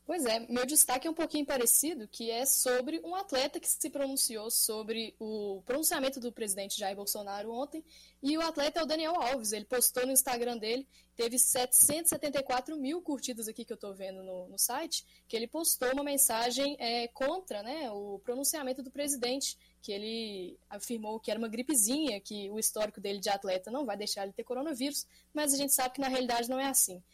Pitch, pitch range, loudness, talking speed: 250 Hz, 220-280 Hz, -31 LUFS, 200 wpm